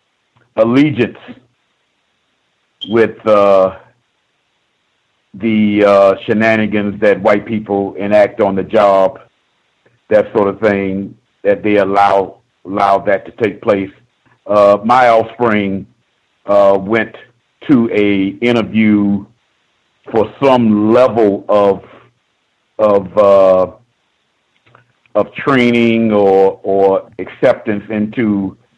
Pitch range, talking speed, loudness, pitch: 100-115 Hz, 95 wpm, -12 LUFS, 105 Hz